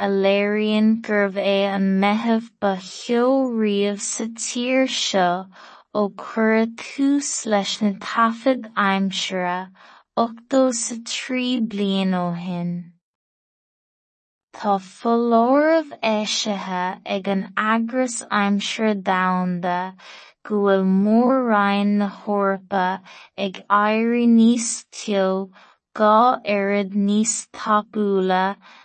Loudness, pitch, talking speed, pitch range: -21 LUFS, 205 Hz, 60 wpm, 195-230 Hz